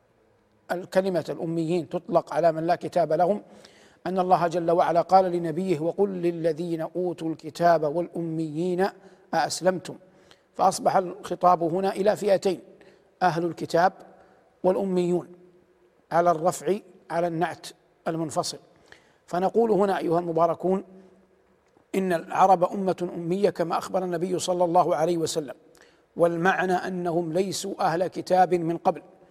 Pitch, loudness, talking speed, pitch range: 180 Hz, -25 LUFS, 115 wpm, 170-185 Hz